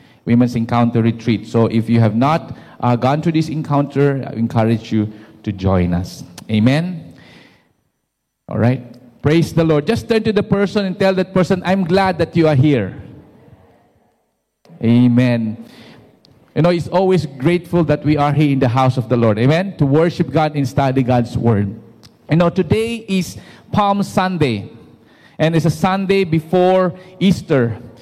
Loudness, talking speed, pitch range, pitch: -16 LUFS, 165 wpm, 115-175 Hz, 145 Hz